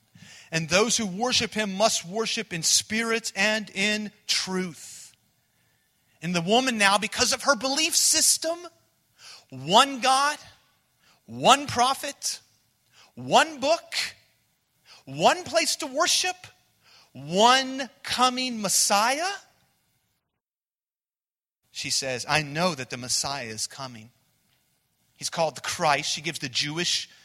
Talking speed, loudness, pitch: 110 wpm, -23 LUFS, 210 Hz